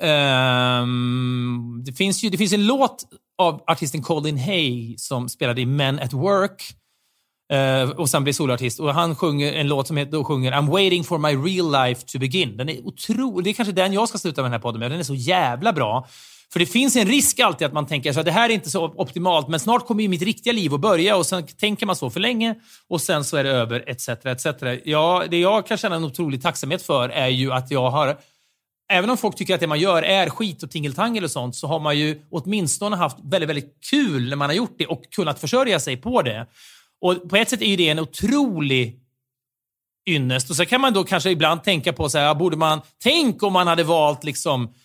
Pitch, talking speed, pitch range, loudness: 160 Hz, 240 wpm, 135-190 Hz, -20 LUFS